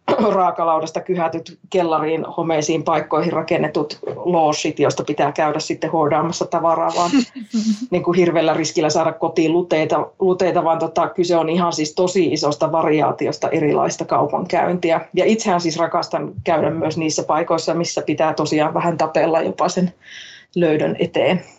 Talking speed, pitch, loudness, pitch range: 135 wpm, 165 Hz, -19 LUFS, 160-180 Hz